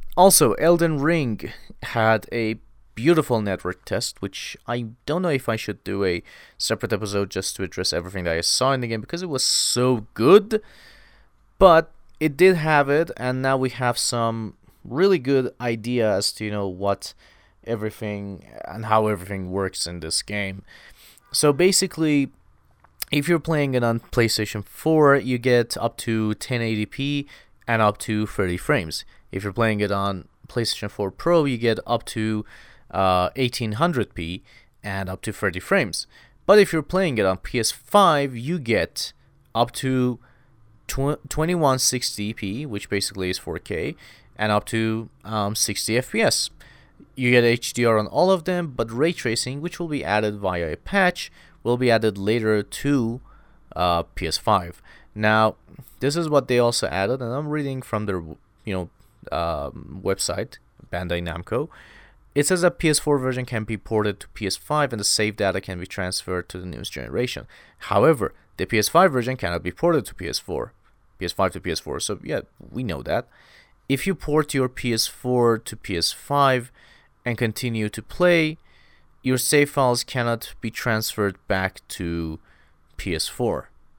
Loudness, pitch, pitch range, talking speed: -22 LUFS, 115 Hz, 100-135 Hz, 155 wpm